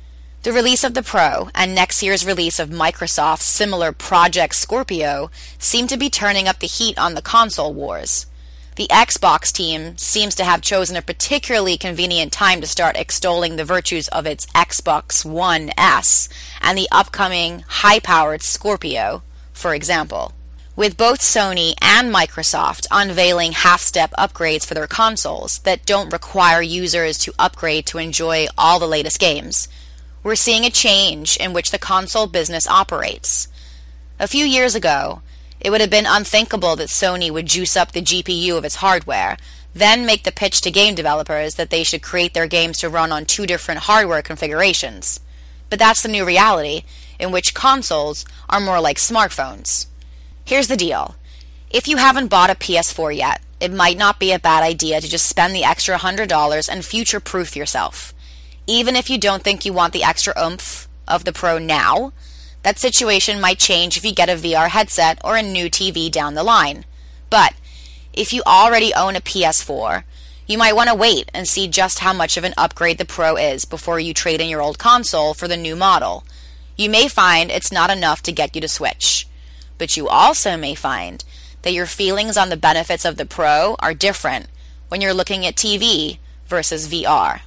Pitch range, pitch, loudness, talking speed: 150-195 Hz, 170 Hz, -15 LUFS, 180 wpm